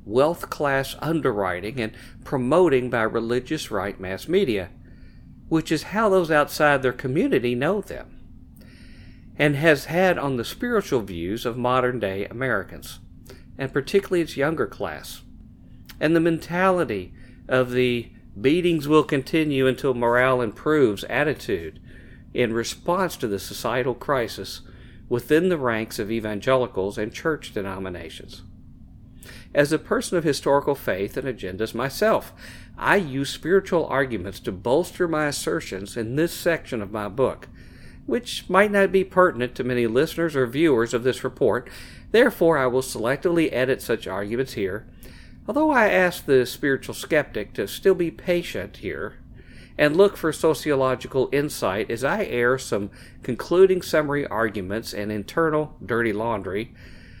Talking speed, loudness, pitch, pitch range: 140 wpm, -23 LUFS, 130 Hz, 115-160 Hz